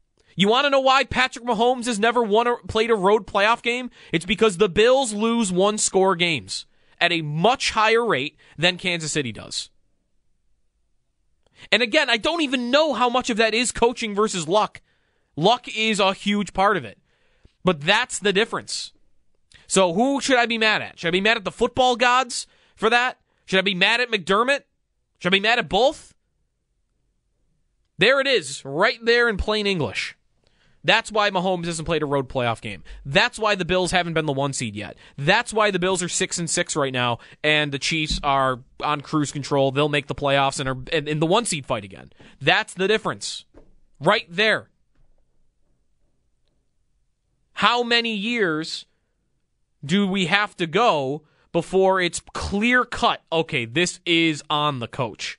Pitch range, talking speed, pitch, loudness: 150-230 Hz, 180 wpm, 190 Hz, -21 LUFS